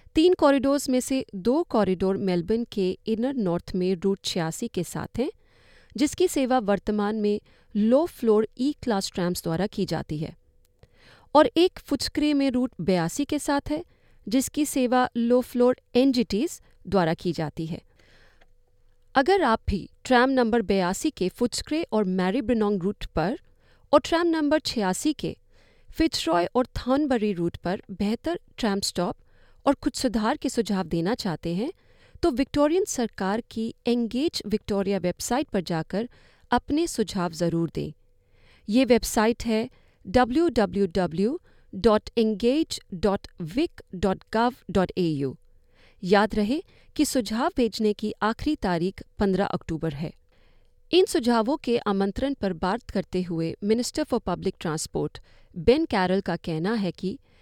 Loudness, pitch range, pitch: -25 LUFS, 185-265 Hz, 215 Hz